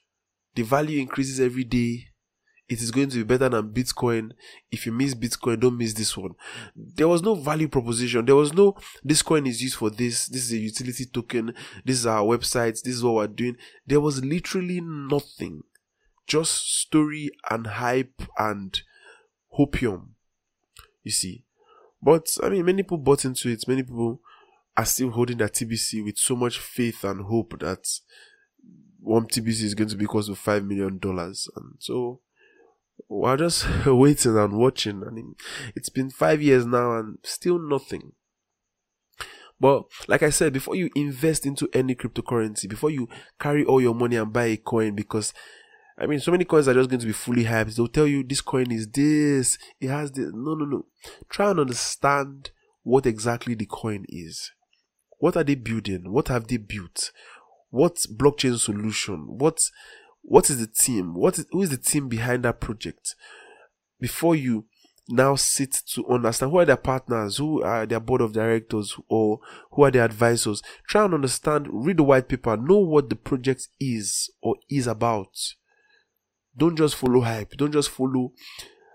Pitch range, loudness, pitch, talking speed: 115-150 Hz, -23 LUFS, 130 Hz, 180 wpm